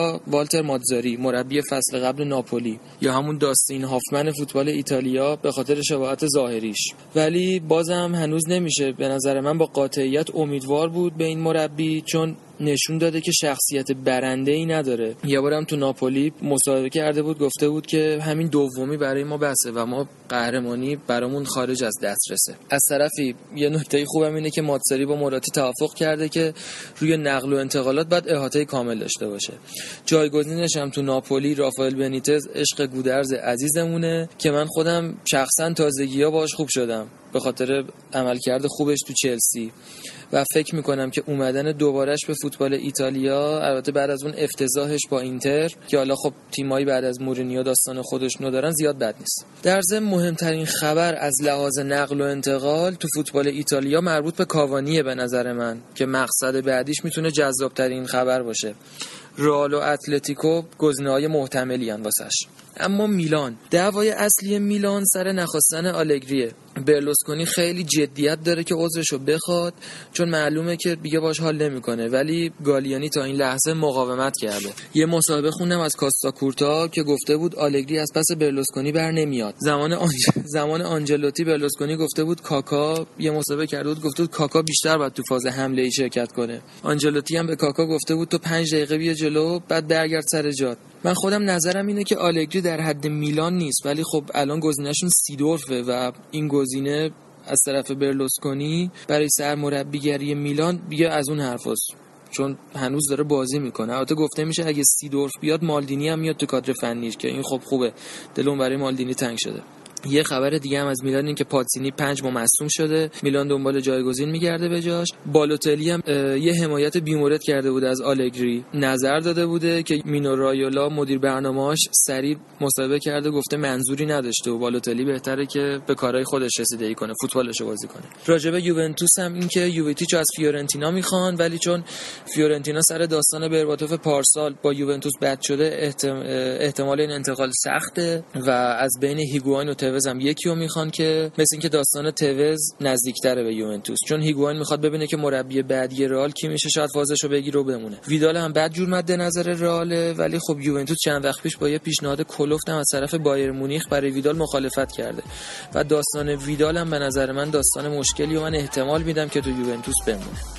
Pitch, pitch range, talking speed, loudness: 145 Hz, 135-155 Hz, 170 wpm, -22 LUFS